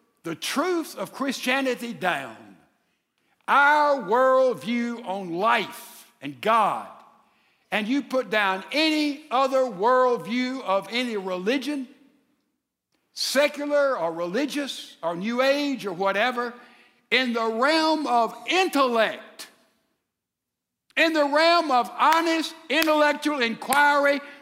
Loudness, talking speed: -23 LUFS, 100 wpm